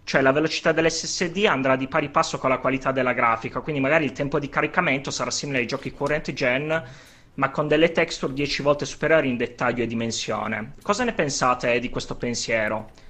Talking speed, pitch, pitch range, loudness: 195 wpm, 135 Hz, 125-160 Hz, -23 LUFS